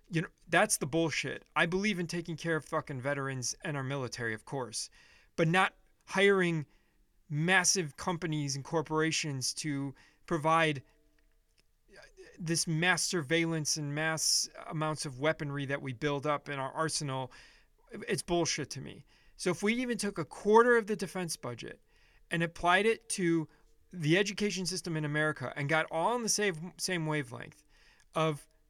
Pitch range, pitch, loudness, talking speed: 150-180 Hz, 160 Hz, -31 LUFS, 155 wpm